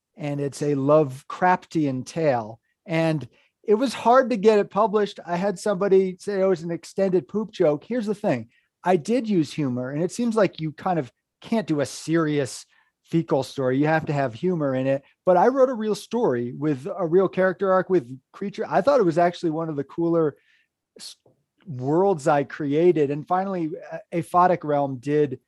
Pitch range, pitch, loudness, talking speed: 145-195 Hz, 170 Hz, -23 LUFS, 190 wpm